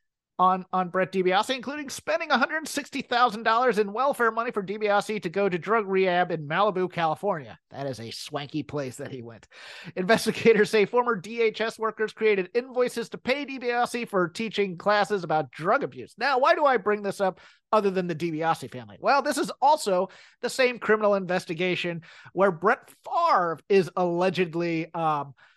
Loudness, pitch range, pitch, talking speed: -25 LUFS, 175-235 Hz, 200 Hz, 165 wpm